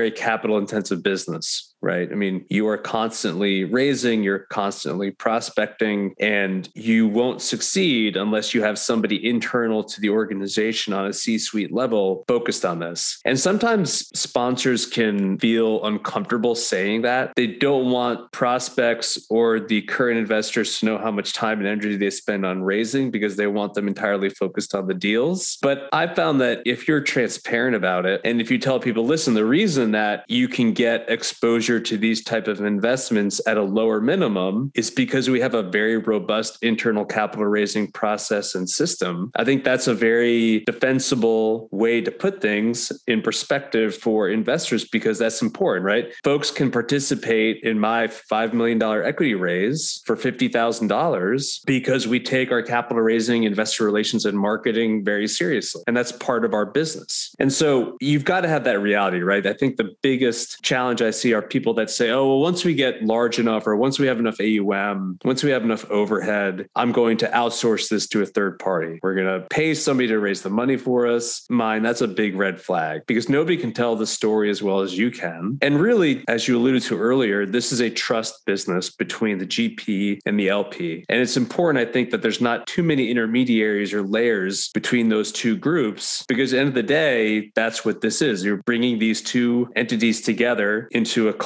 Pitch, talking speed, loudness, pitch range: 115 Hz, 190 wpm, -21 LUFS, 105-125 Hz